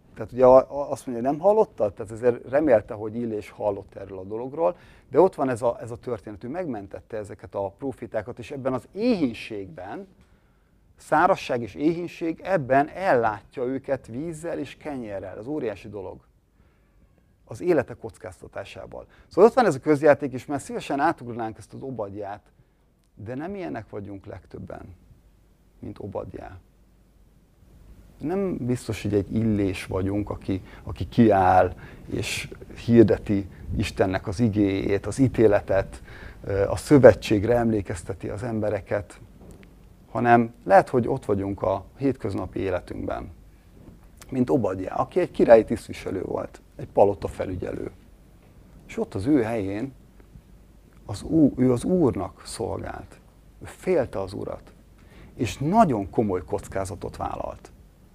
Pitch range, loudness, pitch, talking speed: 100-130 Hz, -24 LUFS, 115 Hz, 130 wpm